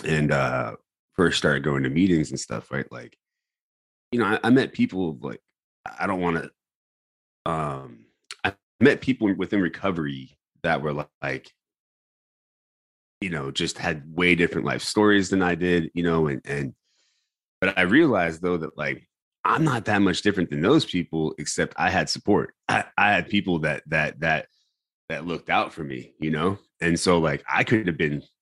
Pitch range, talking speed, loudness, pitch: 75-90 Hz, 180 wpm, -24 LUFS, 80 Hz